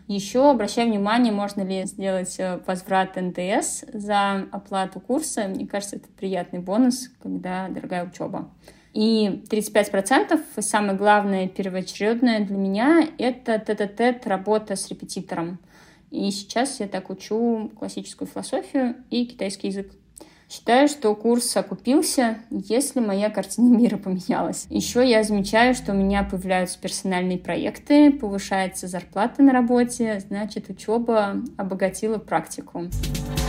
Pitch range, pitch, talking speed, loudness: 190-240 Hz, 205 Hz, 120 wpm, -23 LUFS